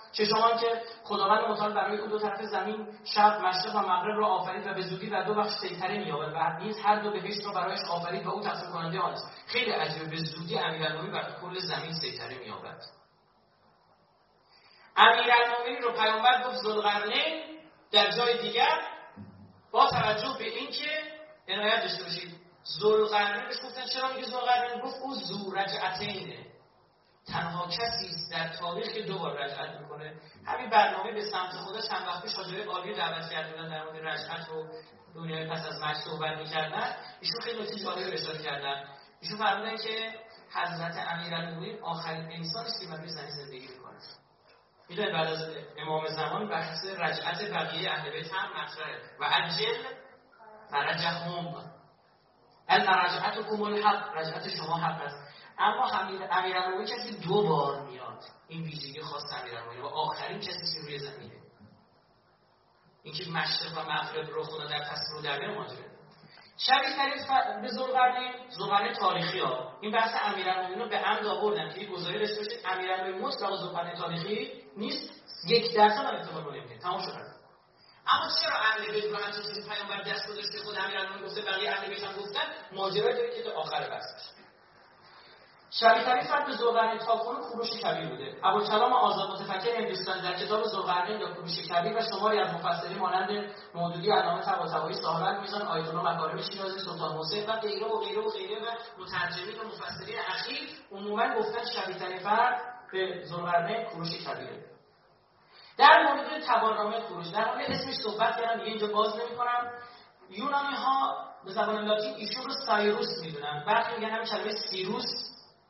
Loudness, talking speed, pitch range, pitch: -30 LUFS, 150 wpm, 170-230 Hz, 205 Hz